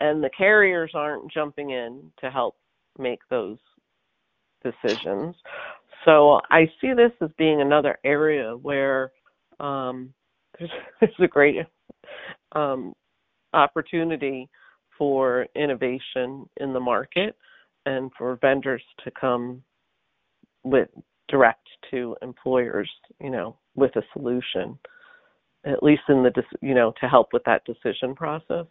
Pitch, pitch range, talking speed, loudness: 140 Hz, 130-160 Hz, 120 wpm, -23 LUFS